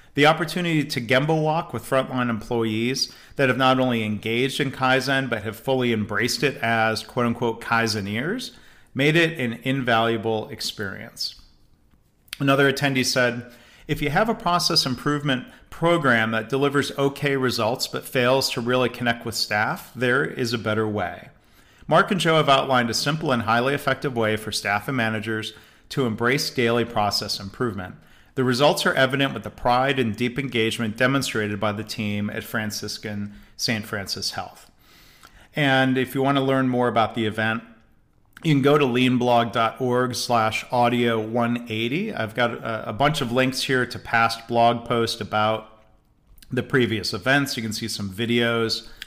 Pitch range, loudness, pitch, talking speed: 110-135 Hz, -22 LUFS, 120 Hz, 160 wpm